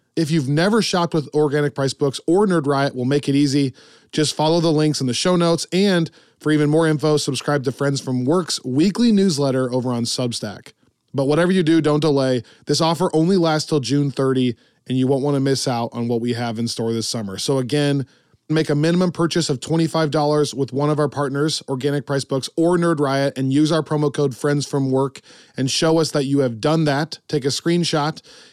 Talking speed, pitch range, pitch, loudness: 220 wpm, 135-160 Hz, 145 Hz, -19 LUFS